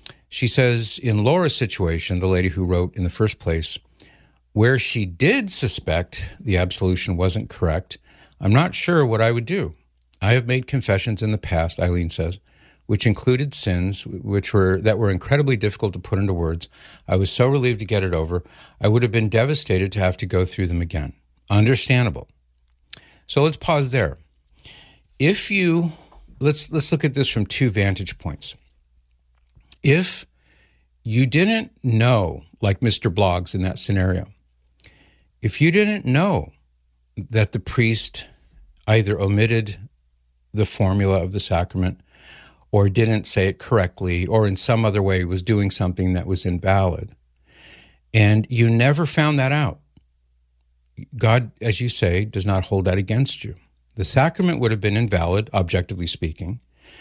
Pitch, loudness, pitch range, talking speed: 100 Hz, -20 LUFS, 90-120 Hz, 160 wpm